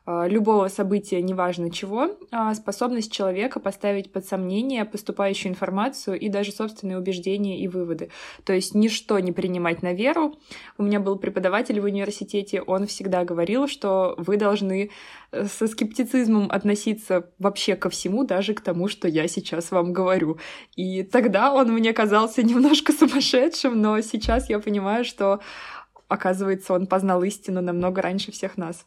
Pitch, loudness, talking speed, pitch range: 200 Hz, -23 LUFS, 145 wpm, 185-220 Hz